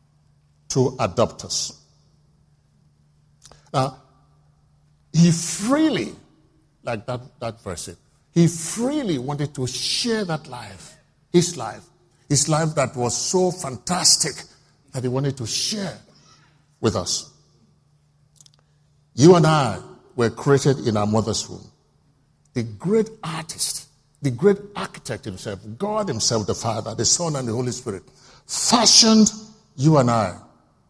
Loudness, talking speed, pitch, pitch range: -21 LUFS, 120 wpm, 145 Hz, 125-160 Hz